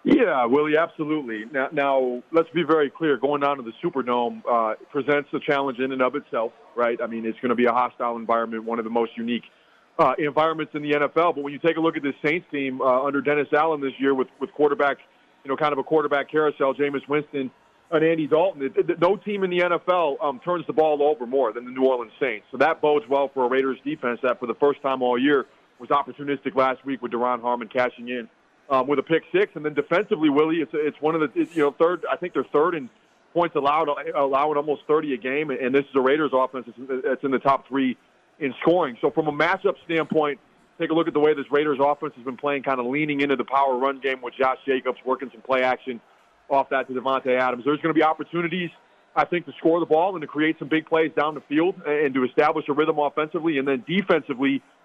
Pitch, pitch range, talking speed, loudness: 140 Hz, 130-155 Hz, 245 wpm, -23 LUFS